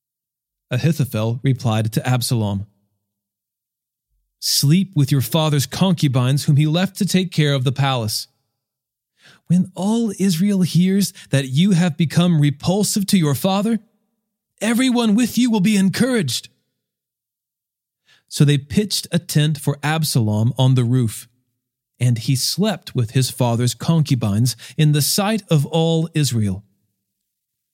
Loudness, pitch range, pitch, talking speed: -18 LUFS, 125-185 Hz, 145 Hz, 130 wpm